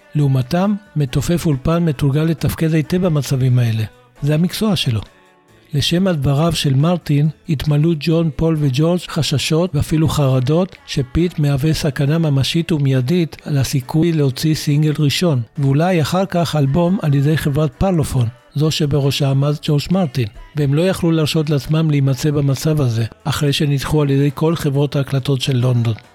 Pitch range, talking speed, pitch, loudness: 140-165 Hz, 140 wpm, 150 Hz, -17 LUFS